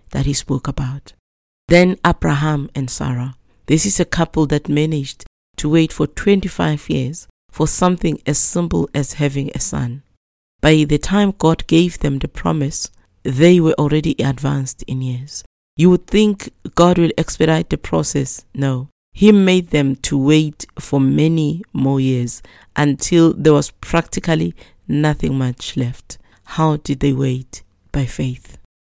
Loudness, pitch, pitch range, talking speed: -17 LUFS, 145 Hz, 130-160 Hz, 150 wpm